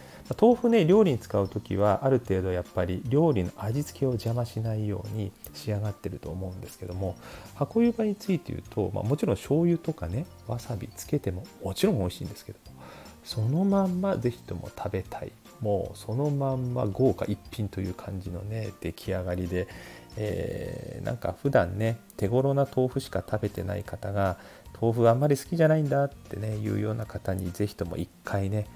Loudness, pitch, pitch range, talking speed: -28 LUFS, 105 Hz, 95-135 Hz, 375 characters per minute